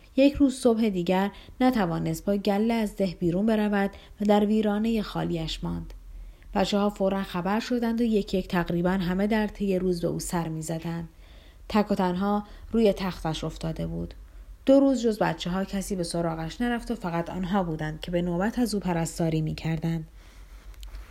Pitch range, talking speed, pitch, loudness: 160-205 Hz, 175 wpm, 185 Hz, -27 LUFS